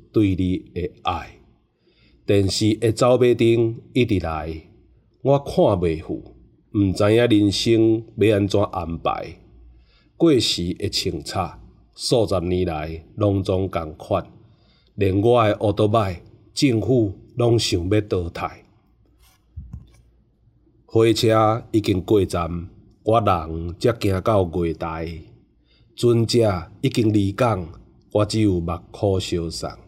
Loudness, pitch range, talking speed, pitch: -21 LUFS, 90-115 Hz, 160 characters per minute, 105 Hz